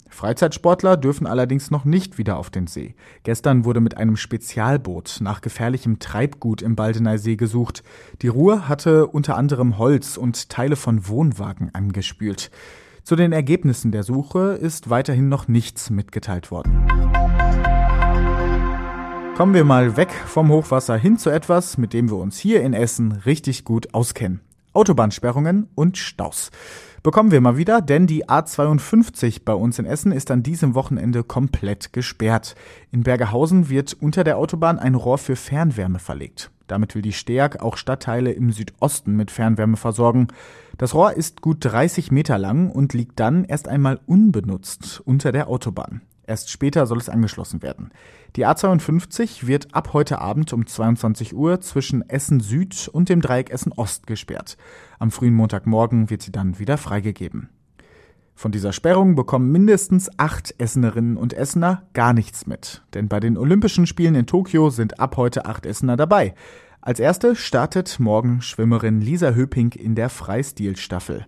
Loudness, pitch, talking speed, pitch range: -19 LUFS, 125 Hz, 155 wpm, 110-155 Hz